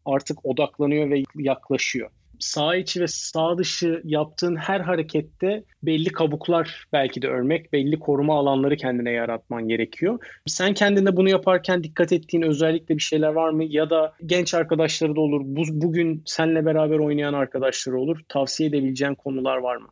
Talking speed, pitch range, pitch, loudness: 155 wpm, 140-170 Hz, 155 Hz, -23 LUFS